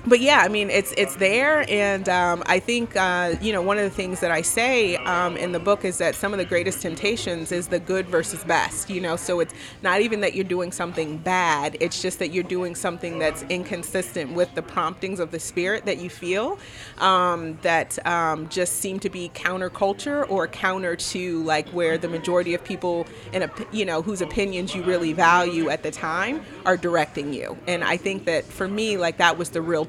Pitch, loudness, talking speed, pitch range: 180 Hz, -23 LUFS, 215 wpm, 170-195 Hz